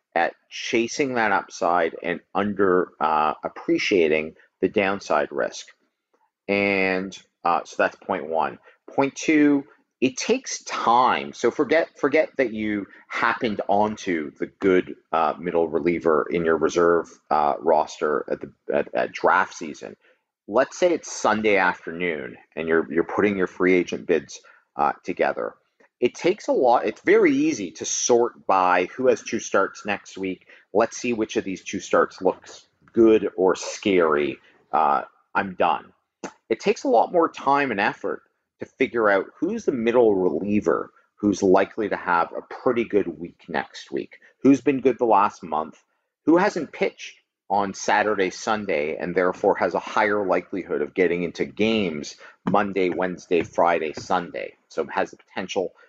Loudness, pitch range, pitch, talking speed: -23 LUFS, 95-145 Hz, 105 Hz, 155 wpm